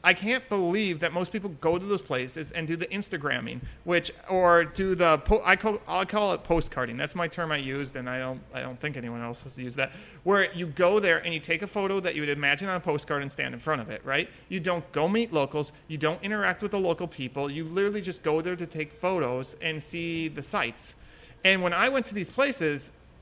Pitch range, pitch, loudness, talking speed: 145-185 Hz, 170 Hz, -28 LUFS, 245 wpm